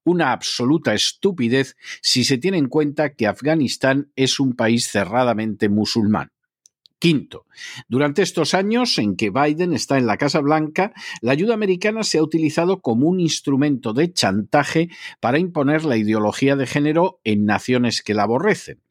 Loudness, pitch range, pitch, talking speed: -19 LUFS, 120-165 Hz, 145 Hz, 155 wpm